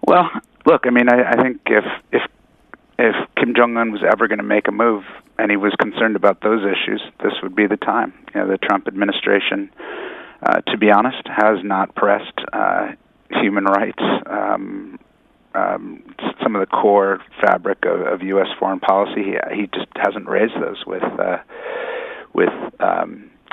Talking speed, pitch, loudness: 180 wpm, 295 Hz, -18 LUFS